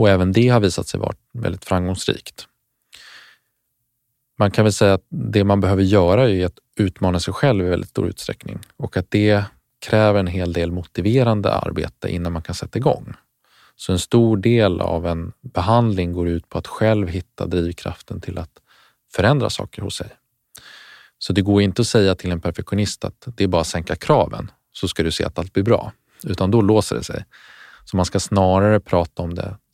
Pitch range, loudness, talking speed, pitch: 90-110 Hz, -19 LUFS, 195 wpm, 100 Hz